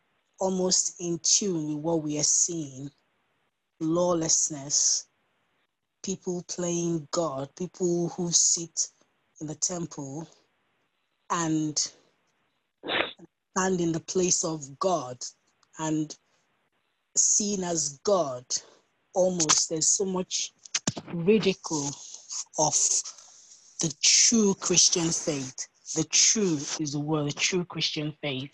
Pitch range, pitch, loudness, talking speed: 150-180 Hz, 165 Hz, -25 LUFS, 100 wpm